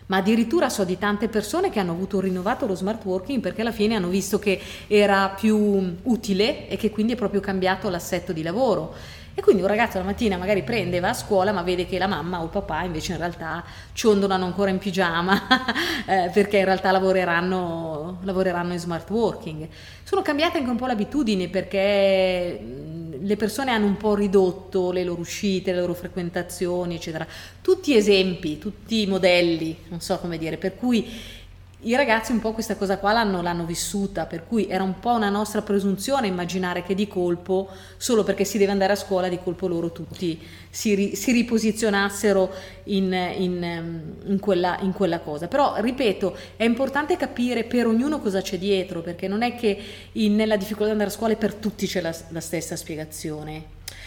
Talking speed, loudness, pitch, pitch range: 190 wpm, -23 LUFS, 195 Hz, 180-215 Hz